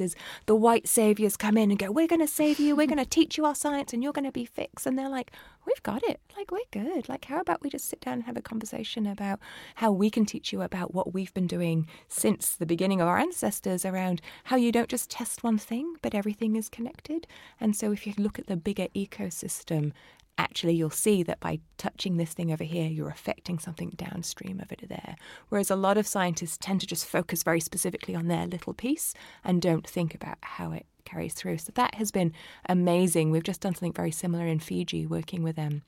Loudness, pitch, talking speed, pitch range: -29 LUFS, 195 Hz, 235 wpm, 170-235 Hz